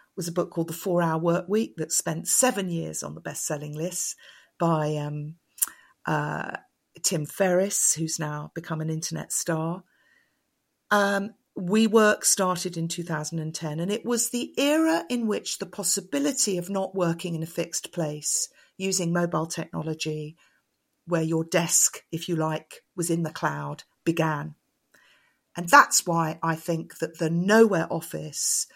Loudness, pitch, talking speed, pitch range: -25 LUFS, 170 Hz, 150 wpm, 160-190 Hz